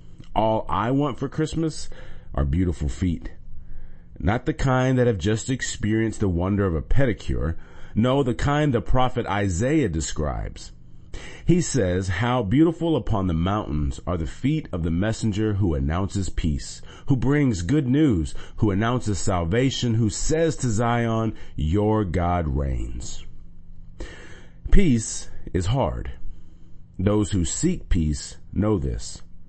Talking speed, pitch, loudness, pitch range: 135 wpm, 100 Hz, -24 LUFS, 85-125 Hz